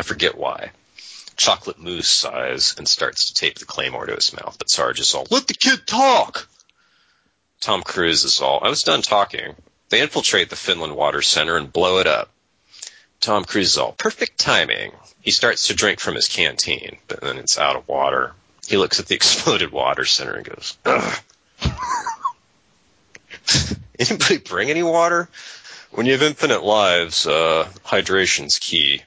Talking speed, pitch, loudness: 170 wpm, 270 Hz, -18 LUFS